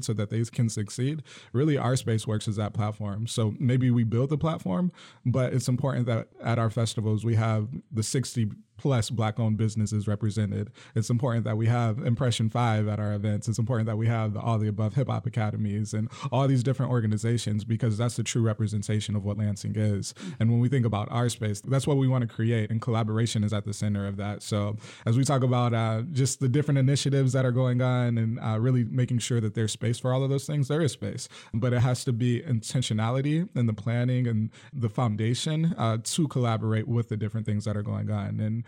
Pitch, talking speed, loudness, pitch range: 115 Hz, 225 wpm, -27 LUFS, 110-125 Hz